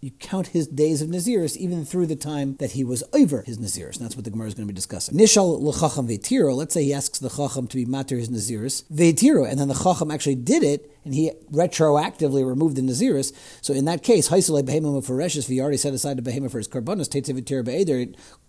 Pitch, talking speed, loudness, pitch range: 140 Hz, 210 wpm, -22 LUFS, 130-160 Hz